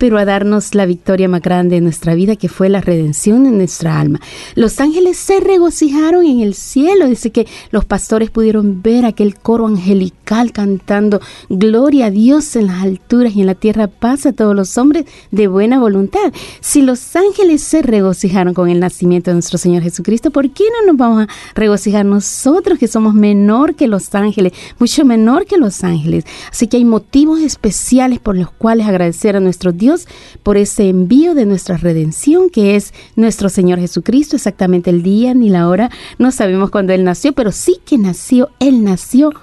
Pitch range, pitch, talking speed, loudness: 190-260 Hz, 210 Hz, 185 wpm, -12 LUFS